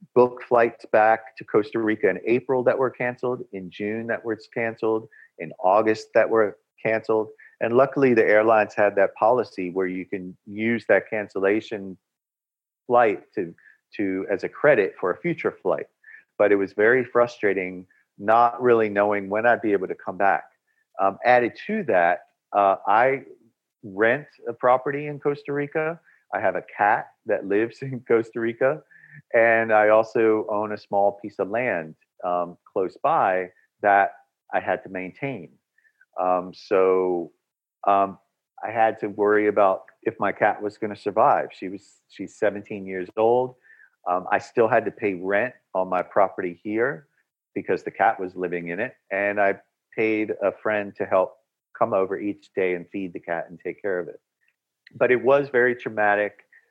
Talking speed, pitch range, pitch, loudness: 170 wpm, 100-120 Hz, 110 Hz, -23 LUFS